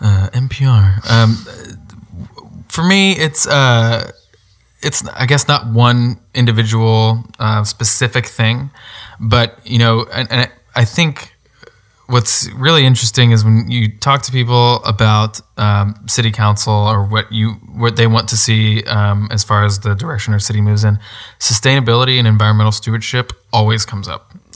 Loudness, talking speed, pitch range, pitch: -13 LUFS, 150 wpm, 105-120 Hz, 115 Hz